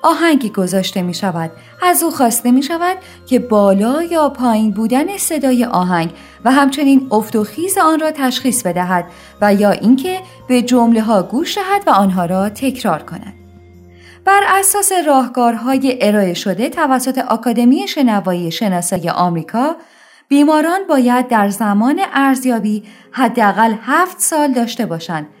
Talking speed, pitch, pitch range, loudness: 140 wpm, 245 Hz, 200-295 Hz, -14 LUFS